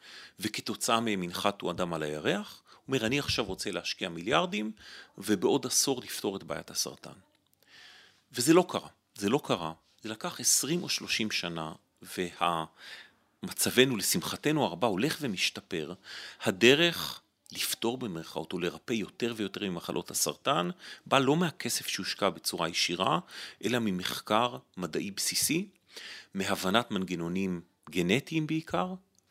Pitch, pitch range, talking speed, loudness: 100 Hz, 90-125 Hz, 120 wpm, -30 LUFS